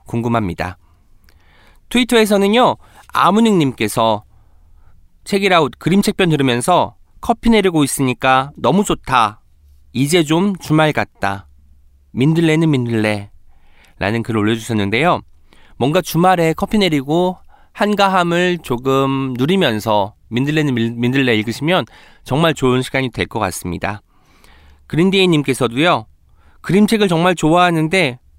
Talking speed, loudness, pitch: 280 characters per minute, -16 LUFS, 130 Hz